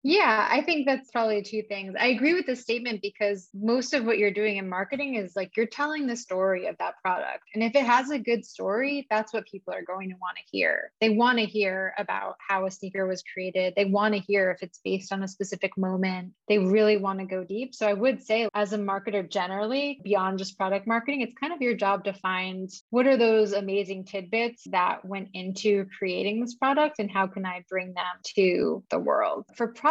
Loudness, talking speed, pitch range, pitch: -27 LUFS, 225 wpm, 190-235 Hz, 205 Hz